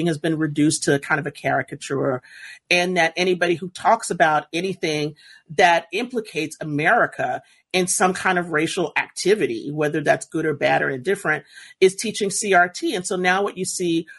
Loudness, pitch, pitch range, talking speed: -21 LUFS, 175 Hz, 155-190 Hz, 175 wpm